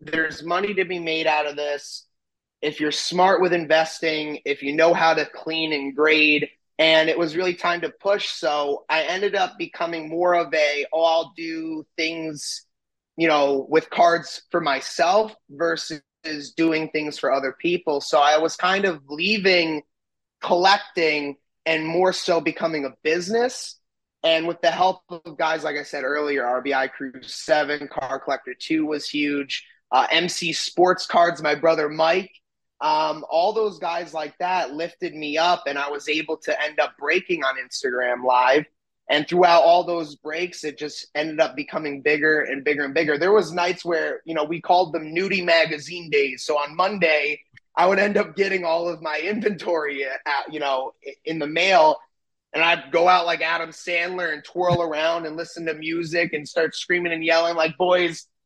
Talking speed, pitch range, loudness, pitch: 180 wpm, 150-175 Hz, -22 LUFS, 160 Hz